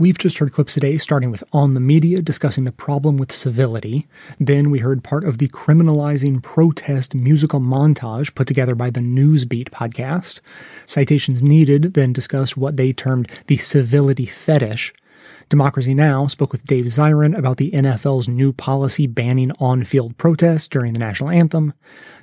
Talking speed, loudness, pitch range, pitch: 160 wpm, -17 LUFS, 130-150 Hz, 140 Hz